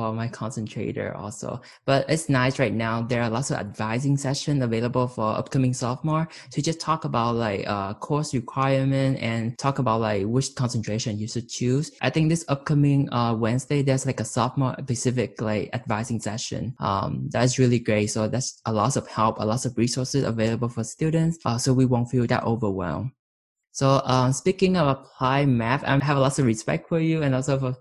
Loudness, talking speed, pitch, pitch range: -24 LUFS, 195 wpm, 125 Hz, 115-135 Hz